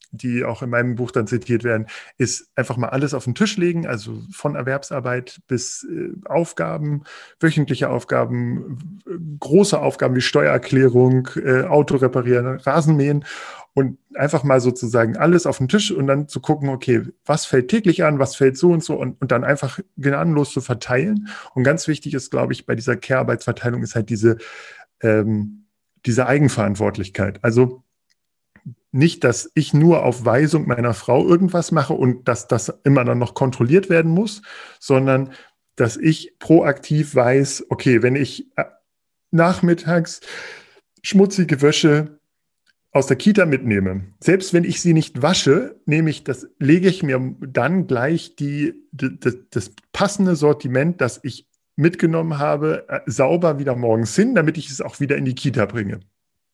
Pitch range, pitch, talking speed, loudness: 125-165 Hz, 140 Hz, 155 wpm, -19 LUFS